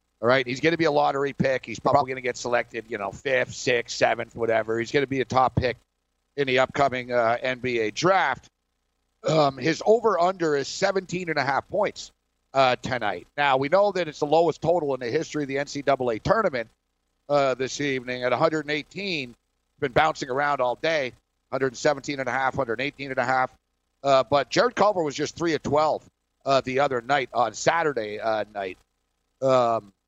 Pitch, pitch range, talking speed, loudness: 135 Hz, 120-150 Hz, 175 wpm, -24 LUFS